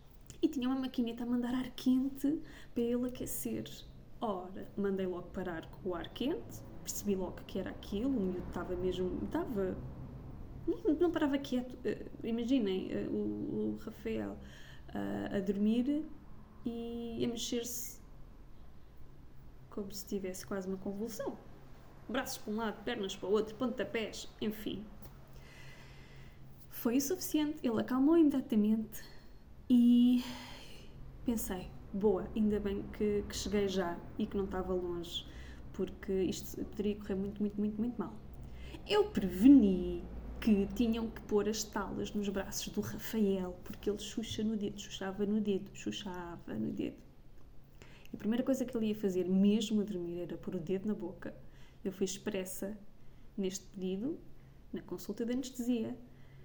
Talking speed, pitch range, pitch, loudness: 140 wpm, 185-240 Hz, 210 Hz, -35 LUFS